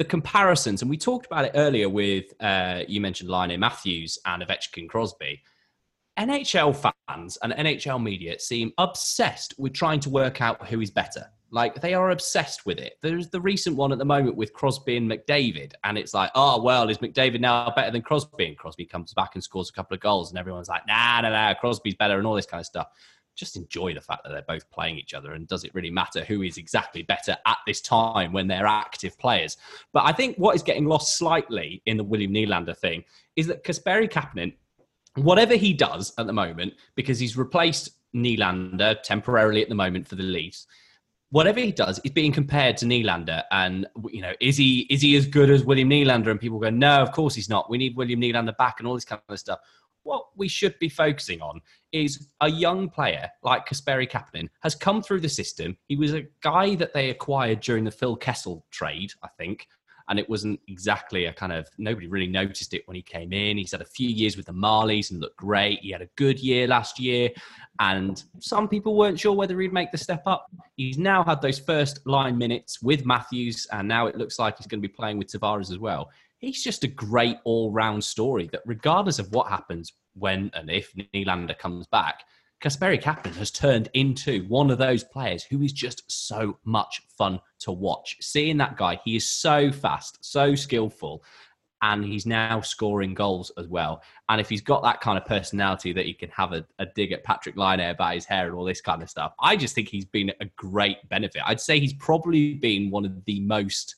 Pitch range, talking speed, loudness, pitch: 100-145 Hz, 220 wpm, -24 LUFS, 115 Hz